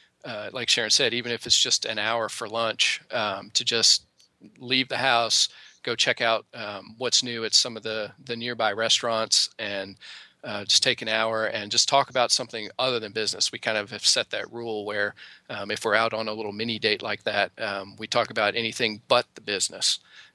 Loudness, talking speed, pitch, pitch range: -24 LUFS, 210 wpm, 115 Hz, 110-120 Hz